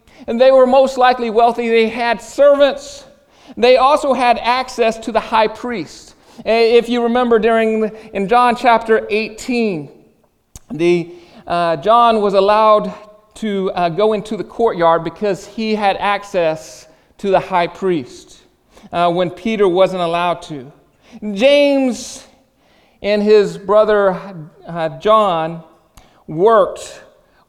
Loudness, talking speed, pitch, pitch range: -15 LUFS, 125 wpm, 215 Hz, 185-240 Hz